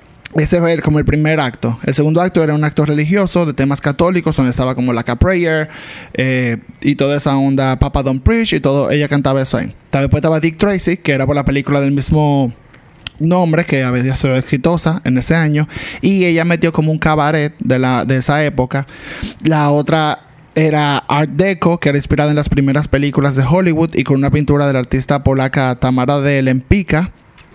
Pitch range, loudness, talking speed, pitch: 135-160 Hz, -14 LUFS, 200 wpm, 145 Hz